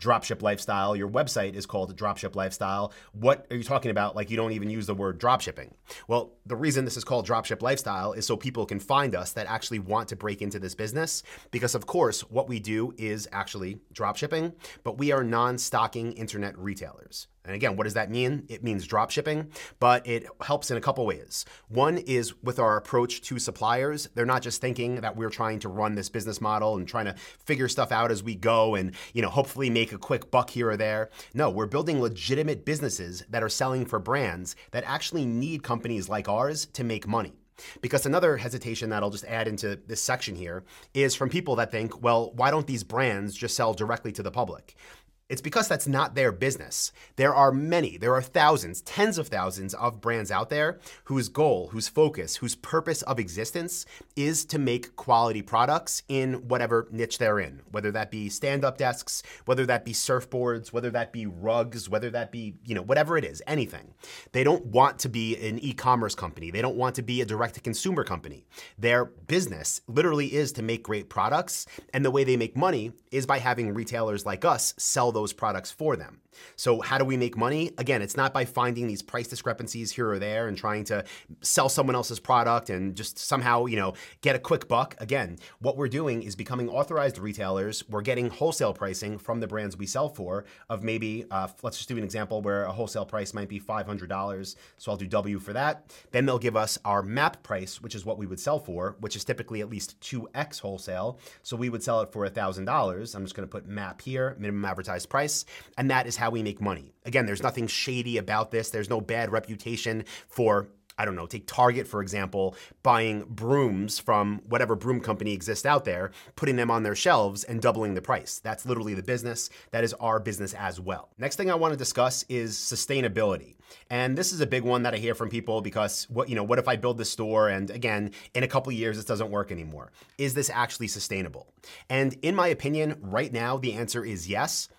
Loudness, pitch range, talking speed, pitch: -28 LUFS, 105-130 Hz, 215 wpm, 115 Hz